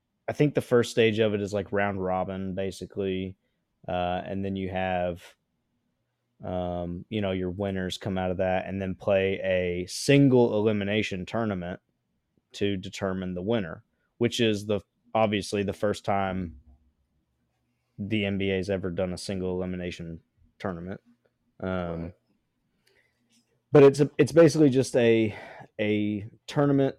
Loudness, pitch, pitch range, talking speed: -26 LUFS, 100 Hz, 90-110 Hz, 140 wpm